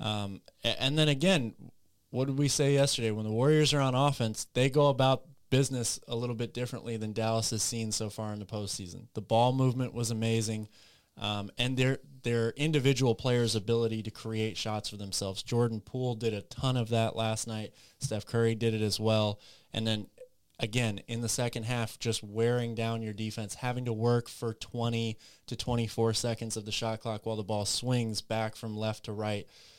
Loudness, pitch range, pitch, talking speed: -31 LUFS, 110-125 Hz, 115 Hz, 195 wpm